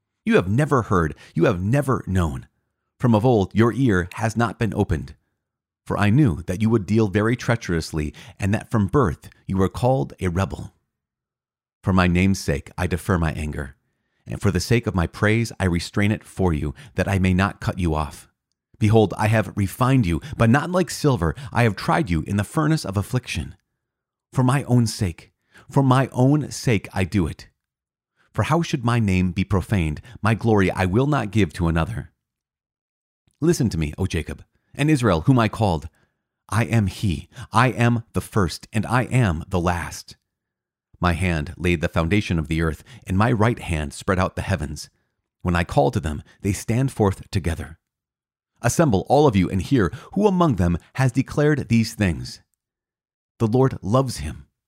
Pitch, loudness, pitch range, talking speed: 100 Hz, -21 LUFS, 90-120 Hz, 185 wpm